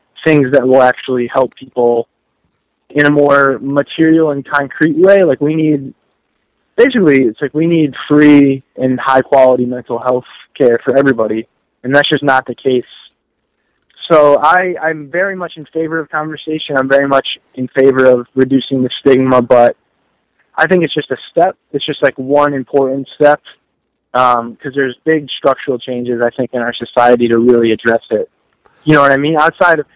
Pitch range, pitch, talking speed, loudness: 125-150 Hz, 140 Hz, 180 wpm, -12 LUFS